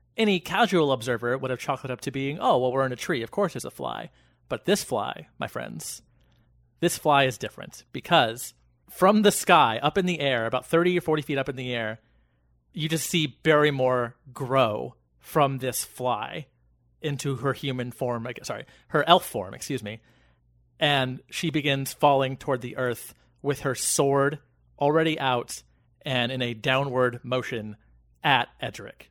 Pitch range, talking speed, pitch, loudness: 120-145 Hz, 175 wpm, 130 Hz, -25 LUFS